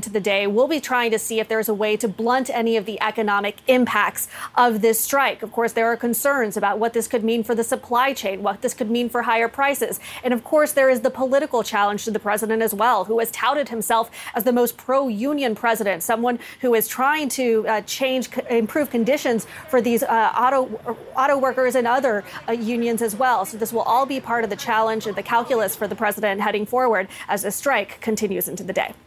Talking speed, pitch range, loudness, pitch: 230 wpm, 215-255 Hz, -21 LUFS, 230 Hz